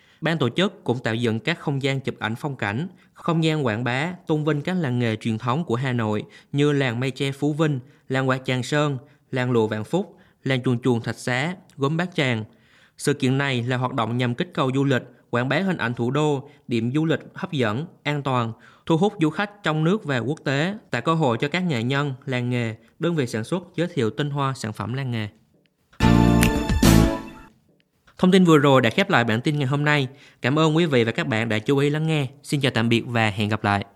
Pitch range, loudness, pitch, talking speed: 120-155 Hz, -23 LUFS, 135 Hz, 240 wpm